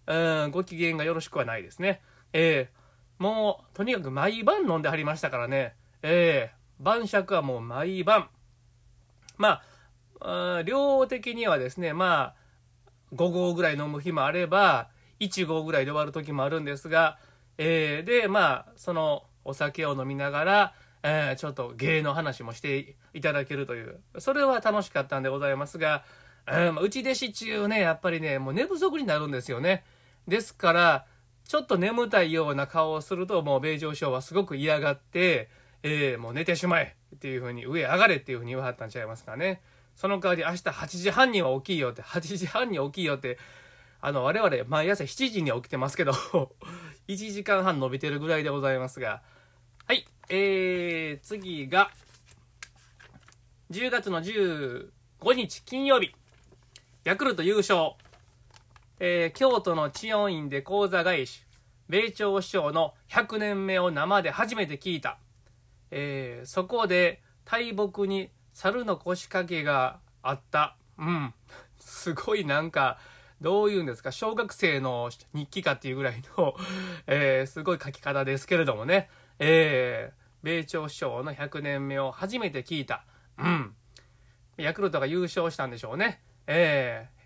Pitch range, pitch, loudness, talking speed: 130-190 Hz, 155 Hz, -27 LUFS, 295 characters per minute